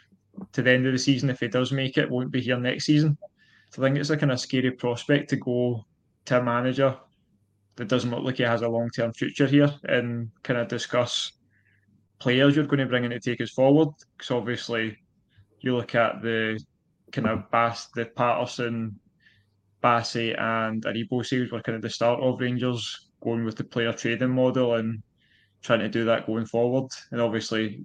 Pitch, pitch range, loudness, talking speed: 120 Hz, 115-130 Hz, -25 LUFS, 200 wpm